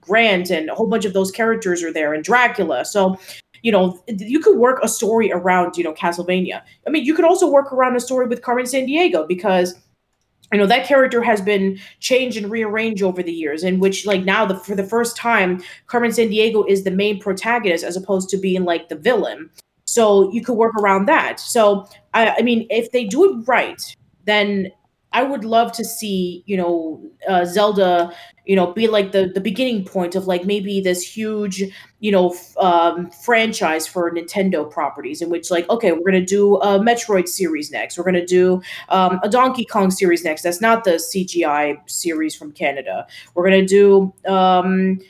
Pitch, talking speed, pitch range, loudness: 195 Hz, 200 wpm, 180-230 Hz, -17 LUFS